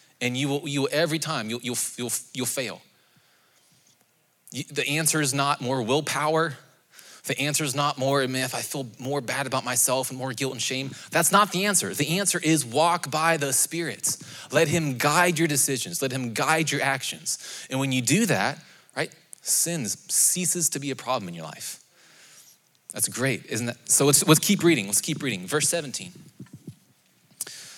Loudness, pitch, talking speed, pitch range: -24 LUFS, 145 Hz, 190 wpm, 130-160 Hz